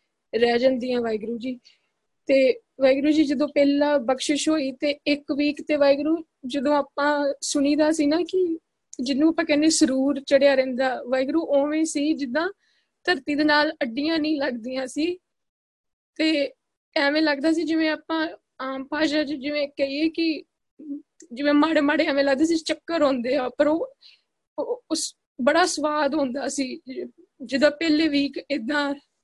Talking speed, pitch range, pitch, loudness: 145 wpm, 275-315 Hz, 295 Hz, -23 LUFS